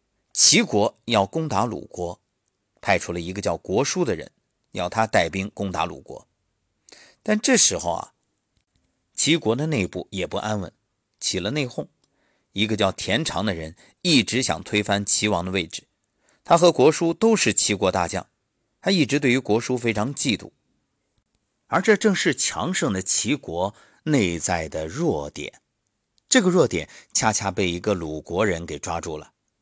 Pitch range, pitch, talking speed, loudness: 90-125 Hz, 105 Hz, 225 characters per minute, -22 LUFS